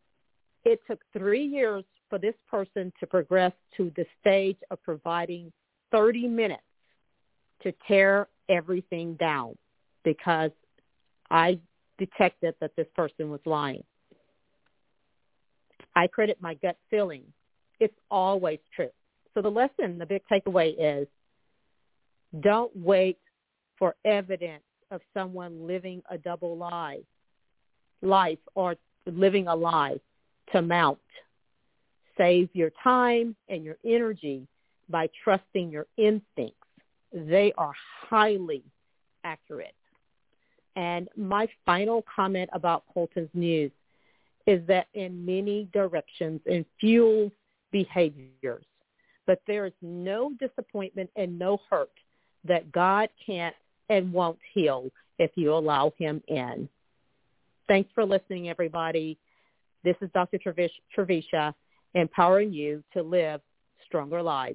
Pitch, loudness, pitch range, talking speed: 185 Hz, -27 LUFS, 165-200 Hz, 115 wpm